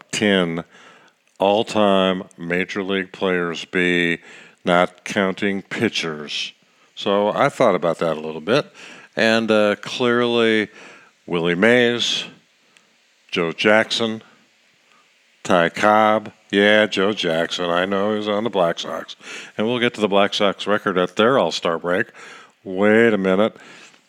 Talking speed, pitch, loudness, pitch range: 130 wpm, 100 Hz, -19 LUFS, 90-110 Hz